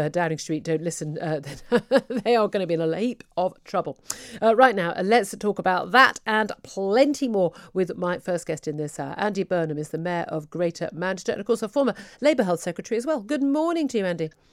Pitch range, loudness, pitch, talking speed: 165-230 Hz, -24 LUFS, 185 Hz, 225 wpm